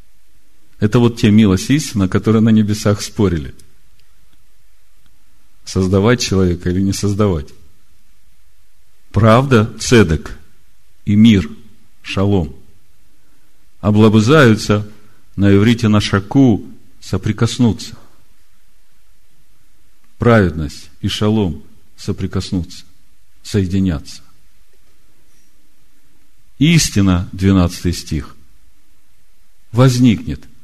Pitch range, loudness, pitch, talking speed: 90-110 Hz, -14 LUFS, 100 Hz, 65 wpm